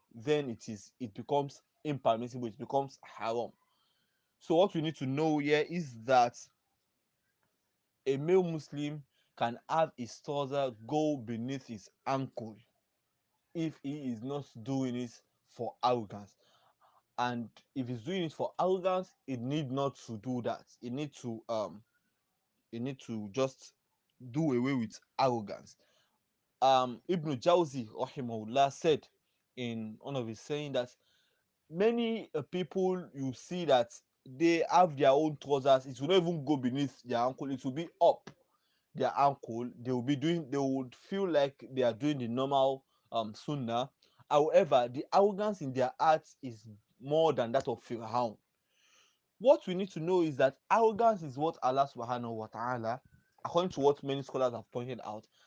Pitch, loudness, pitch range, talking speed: 135 Hz, -33 LUFS, 120-155 Hz, 160 wpm